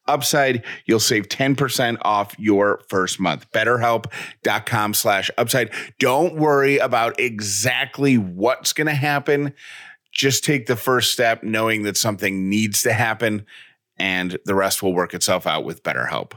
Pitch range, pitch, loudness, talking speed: 105-135 Hz, 115 Hz, -19 LUFS, 145 wpm